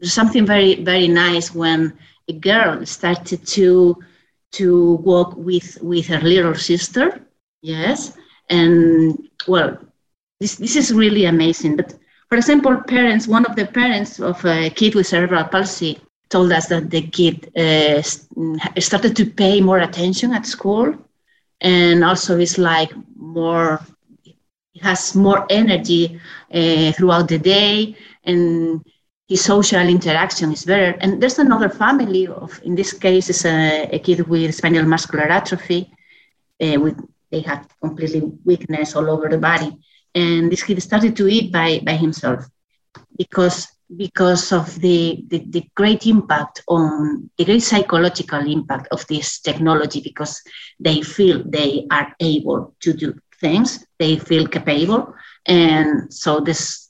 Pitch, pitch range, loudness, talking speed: 175 Hz, 160-195 Hz, -16 LUFS, 145 wpm